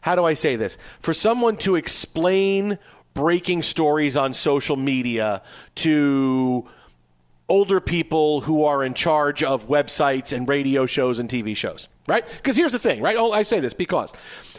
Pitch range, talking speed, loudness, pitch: 135-175 Hz, 165 wpm, -21 LUFS, 150 Hz